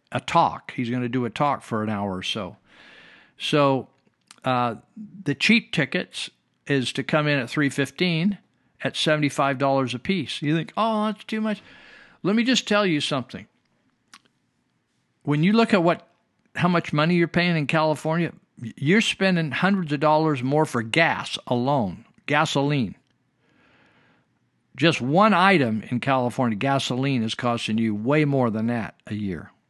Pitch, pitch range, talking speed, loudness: 145 Hz, 125-175 Hz, 160 wpm, -23 LUFS